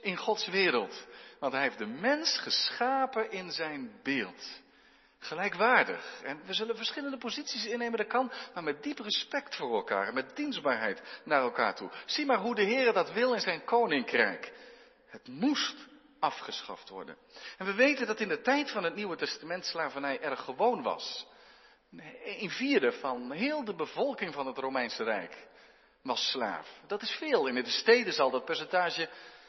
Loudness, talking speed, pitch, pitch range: -31 LUFS, 165 wpm, 235 Hz, 205-275 Hz